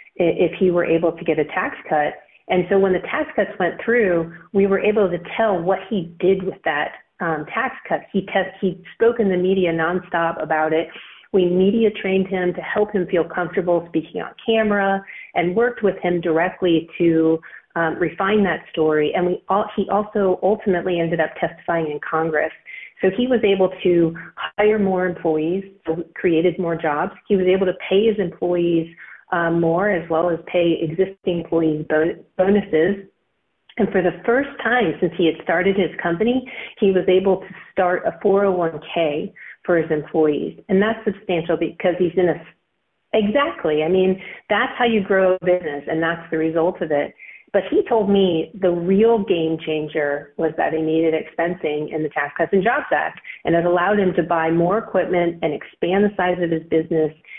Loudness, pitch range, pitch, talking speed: -20 LUFS, 165-195 Hz, 180 Hz, 185 wpm